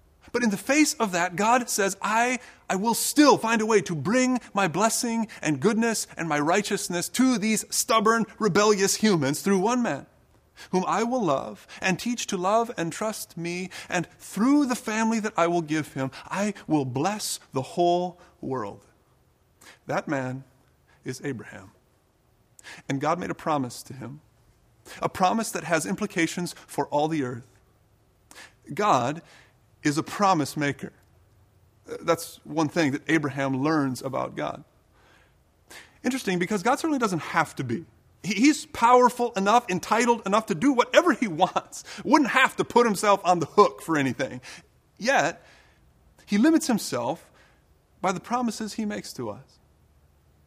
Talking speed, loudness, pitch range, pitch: 155 wpm, -25 LUFS, 145-225 Hz, 185 Hz